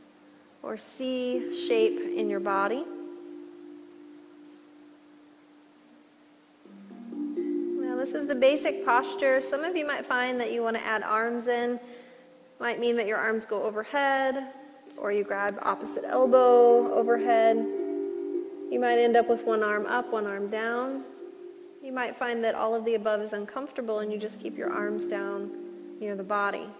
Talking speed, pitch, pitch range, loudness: 150 wpm, 260 Hz, 230-315 Hz, -27 LUFS